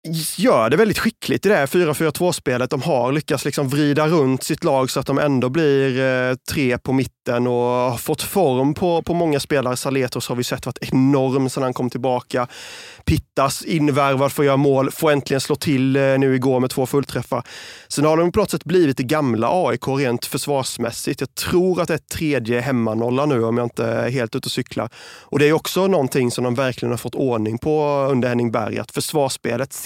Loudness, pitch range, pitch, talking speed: -19 LUFS, 125-150 Hz, 135 Hz, 205 wpm